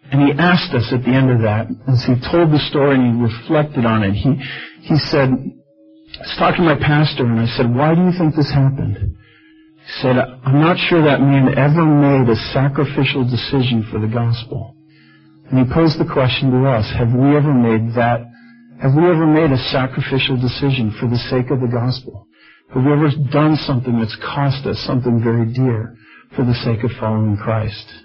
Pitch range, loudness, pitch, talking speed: 120-150 Hz, -16 LUFS, 130 Hz, 200 wpm